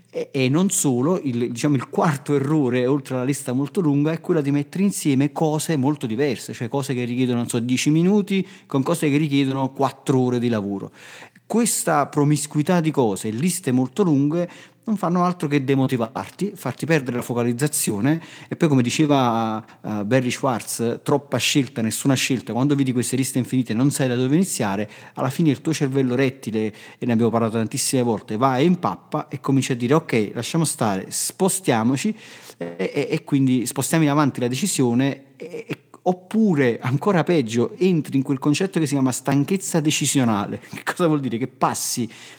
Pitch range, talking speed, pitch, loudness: 125-155 Hz, 175 wpm, 140 Hz, -21 LUFS